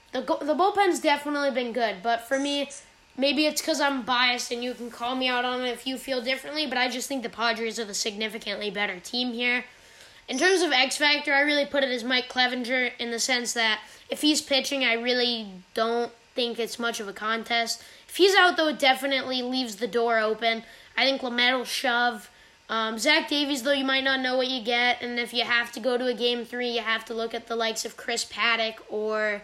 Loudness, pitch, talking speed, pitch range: -25 LUFS, 245 Hz, 230 wpm, 230-270 Hz